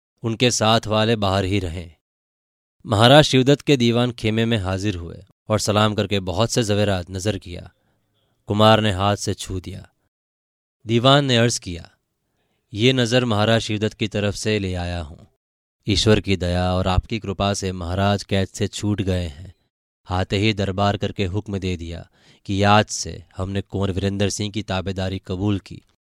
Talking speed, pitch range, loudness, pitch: 170 wpm, 95-110 Hz, -20 LUFS, 100 Hz